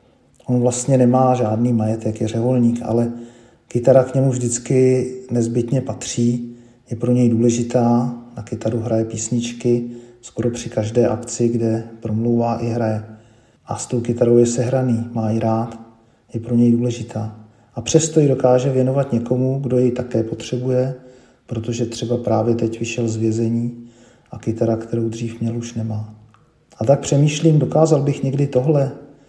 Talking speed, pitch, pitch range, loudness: 150 wpm, 120 Hz, 115-125 Hz, -19 LUFS